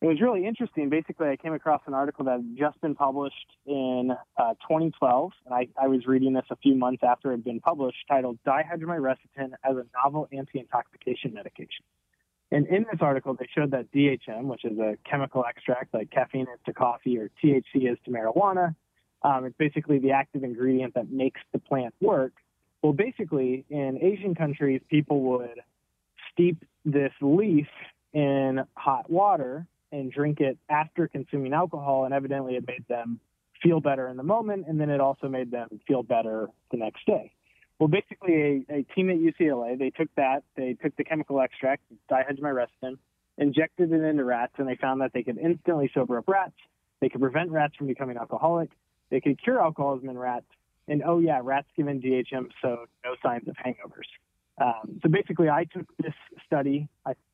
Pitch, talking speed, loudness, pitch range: 140 Hz, 185 wpm, -27 LUFS, 130-155 Hz